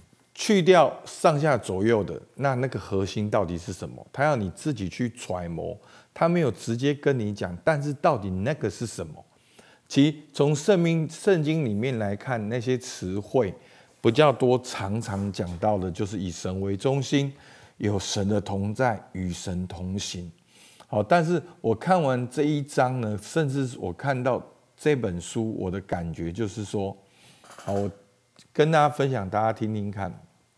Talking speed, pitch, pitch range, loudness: 230 characters per minute, 115 Hz, 100-140 Hz, -26 LUFS